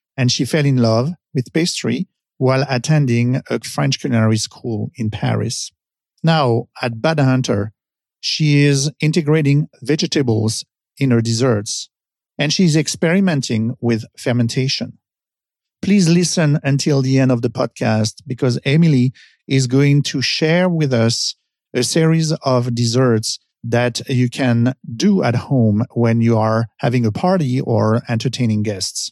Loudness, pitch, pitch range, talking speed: -17 LUFS, 130 Hz, 115-150 Hz, 135 wpm